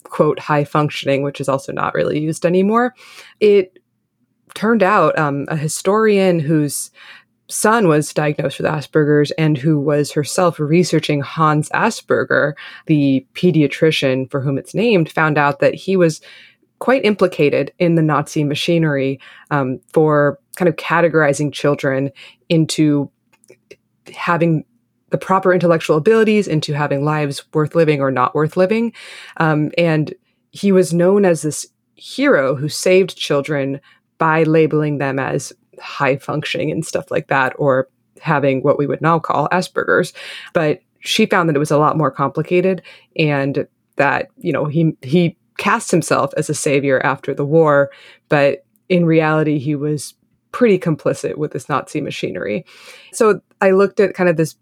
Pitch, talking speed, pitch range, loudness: 155 Hz, 150 wpm, 145-175 Hz, -16 LUFS